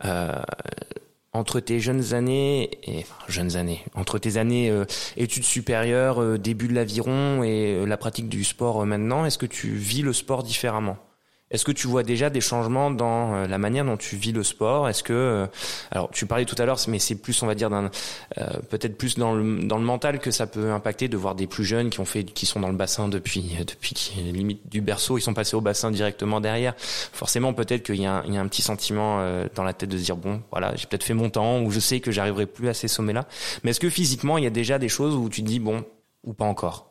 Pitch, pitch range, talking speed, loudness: 110 Hz, 105-120 Hz, 250 wpm, -25 LUFS